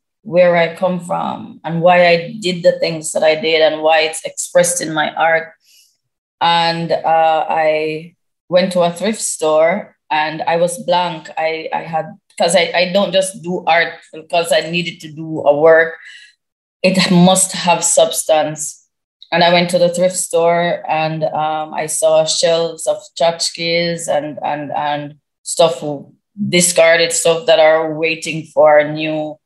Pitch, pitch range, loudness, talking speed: 165 Hz, 155-175 Hz, -14 LUFS, 160 wpm